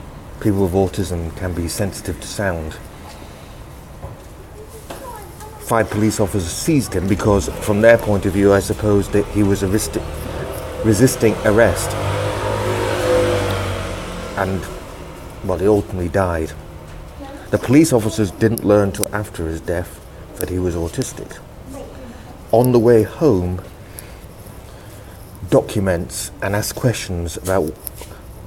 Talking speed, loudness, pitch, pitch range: 115 wpm, -18 LUFS, 100 Hz, 90-105 Hz